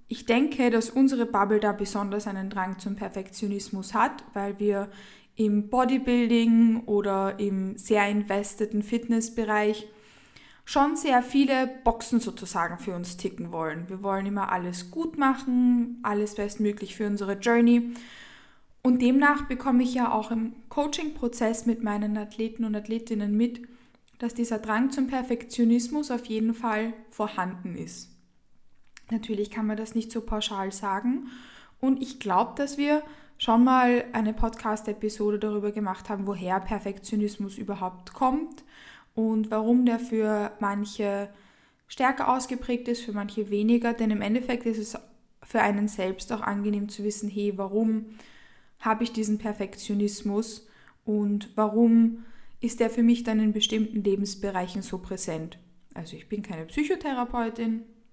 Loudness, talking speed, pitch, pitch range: -27 LUFS, 140 wpm, 220 Hz, 205-235 Hz